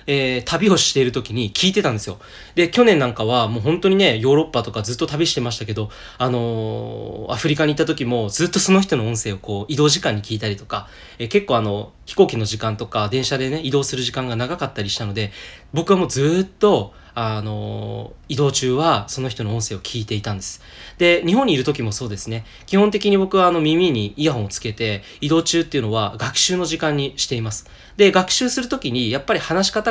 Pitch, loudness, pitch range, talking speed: 125 Hz, -19 LUFS, 110-165 Hz, 430 characters per minute